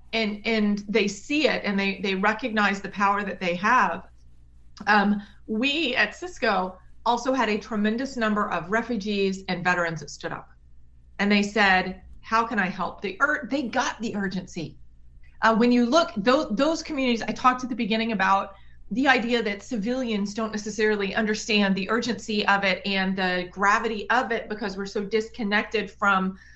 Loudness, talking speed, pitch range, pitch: -24 LUFS, 175 wpm, 195-230 Hz, 210 Hz